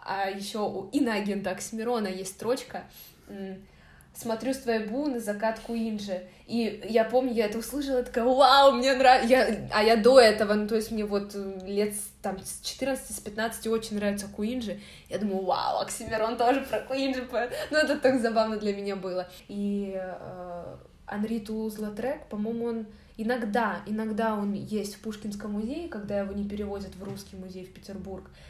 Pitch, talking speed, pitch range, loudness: 220 Hz, 160 wpm, 200-240 Hz, -27 LUFS